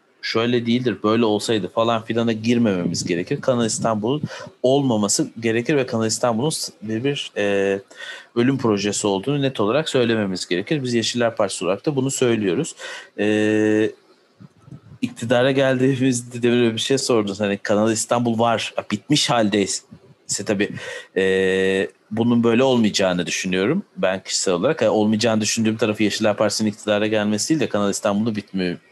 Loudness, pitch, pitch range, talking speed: -20 LUFS, 115 Hz, 105-120 Hz, 140 wpm